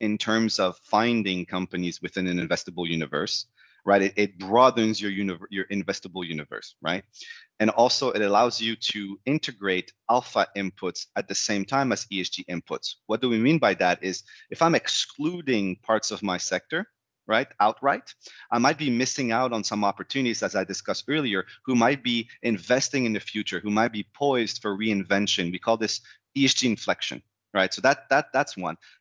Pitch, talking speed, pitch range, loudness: 105 Hz, 180 wpm, 95-115 Hz, -25 LUFS